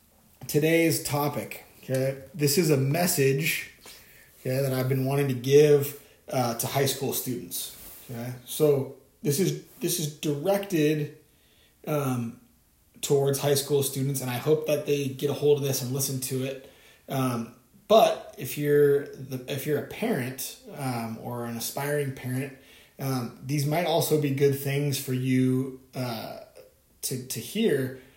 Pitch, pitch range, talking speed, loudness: 140 Hz, 130-145 Hz, 155 wpm, -27 LUFS